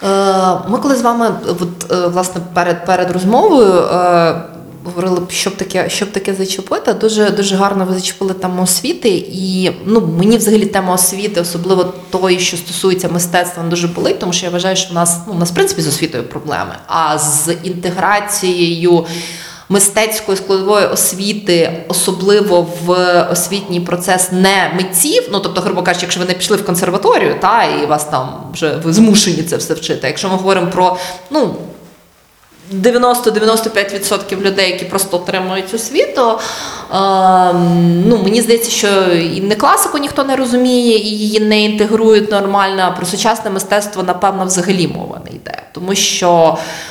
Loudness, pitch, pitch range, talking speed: -13 LUFS, 185 Hz, 175-205 Hz, 155 wpm